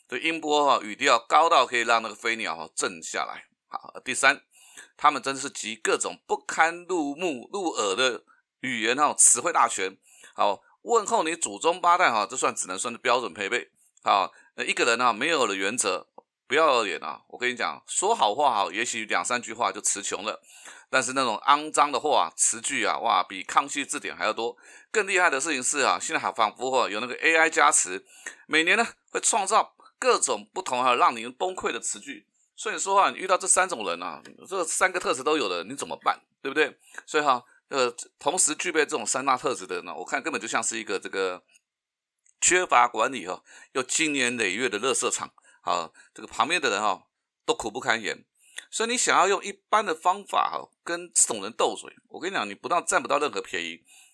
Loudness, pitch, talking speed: -25 LUFS, 175 Hz, 300 characters per minute